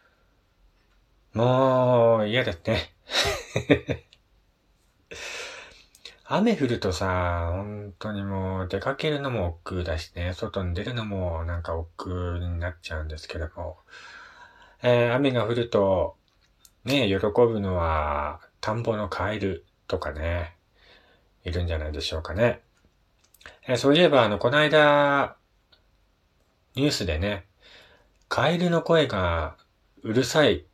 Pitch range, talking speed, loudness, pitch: 85-125 Hz, 225 characters per minute, -25 LUFS, 100 Hz